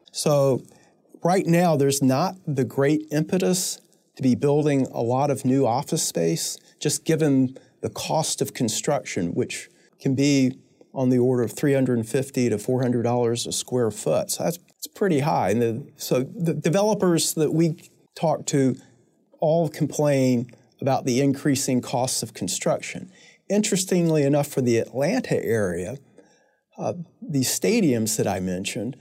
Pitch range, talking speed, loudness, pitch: 125-165 Hz, 145 wpm, -23 LUFS, 140 Hz